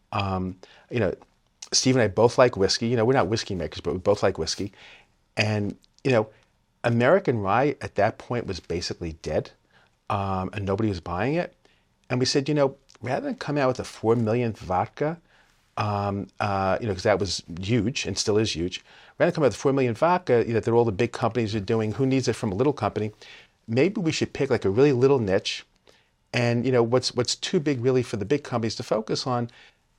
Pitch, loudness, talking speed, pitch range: 115 Hz, -25 LUFS, 220 wpm, 100-130 Hz